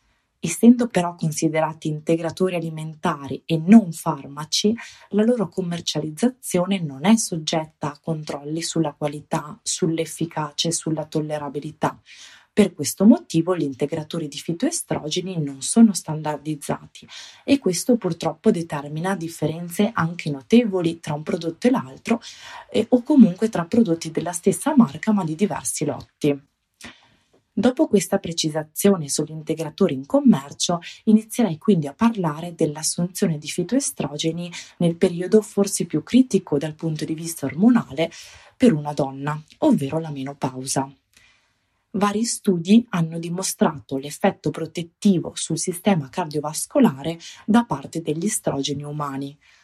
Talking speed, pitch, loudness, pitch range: 120 wpm, 165 Hz, -22 LUFS, 150-200 Hz